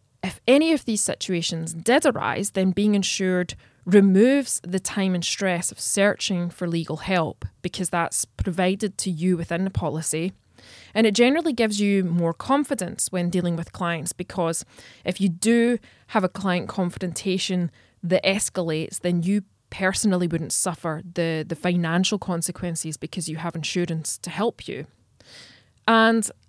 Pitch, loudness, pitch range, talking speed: 185 Hz, -23 LUFS, 170-200 Hz, 150 wpm